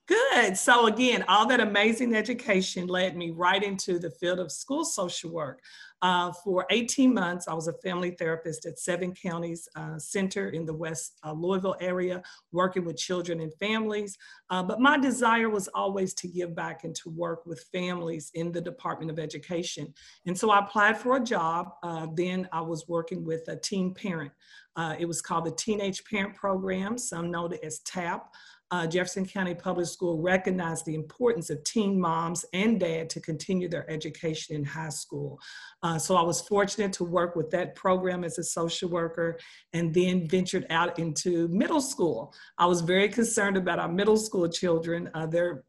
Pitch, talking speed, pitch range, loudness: 180 Hz, 185 wpm, 165-195 Hz, -28 LUFS